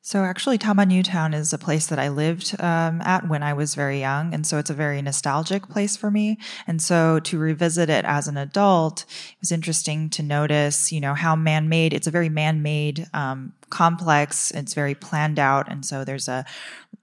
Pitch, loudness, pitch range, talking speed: 155 Hz, -22 LUFS, 145-170 Hz, 200 wpm